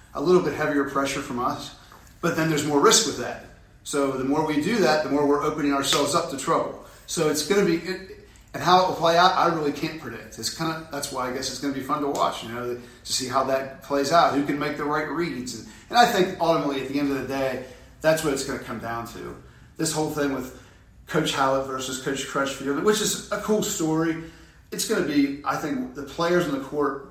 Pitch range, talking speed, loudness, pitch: 130-160 Hz, 250 wpm, -24 LUFS, 140 Hz